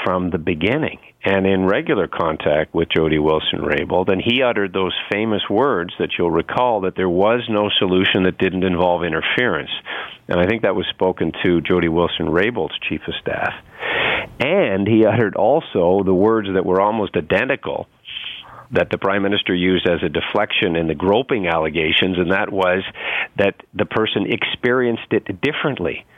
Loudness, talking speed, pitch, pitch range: -18 LUFS, 165 wpm, 95 Hz, 90-100 Hz